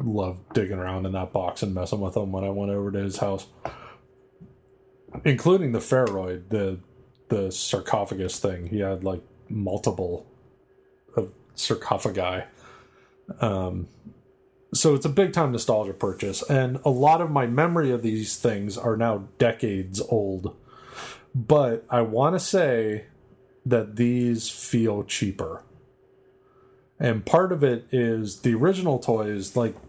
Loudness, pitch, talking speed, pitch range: -25 LUFS, 115 Hz, 140 wpm, 100-135 Hz